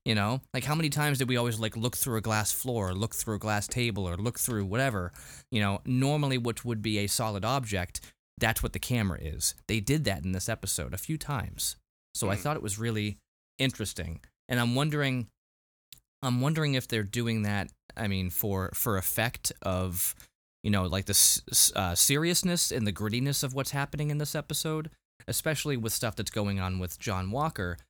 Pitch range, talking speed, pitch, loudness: 95-130 Hz, 200 wpm, 110 Hz, -29 LUFS